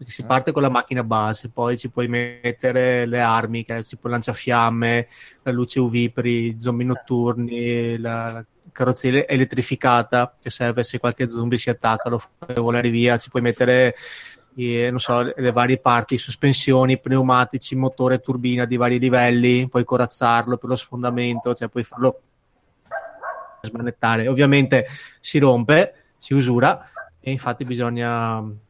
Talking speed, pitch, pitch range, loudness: 145 wpm, 125 Hz, 120-130 Hz, -20 LUFS